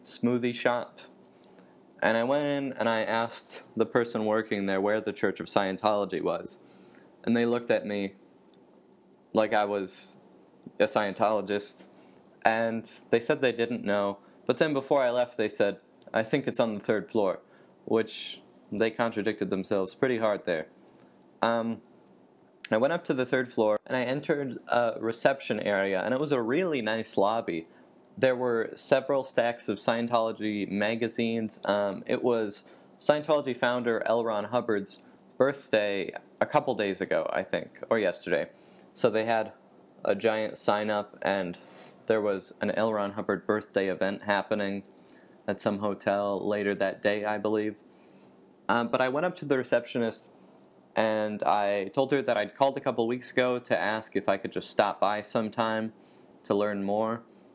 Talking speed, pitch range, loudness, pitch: 165 wpm, 100-120 Hz, -29 LUFS, 110 Hz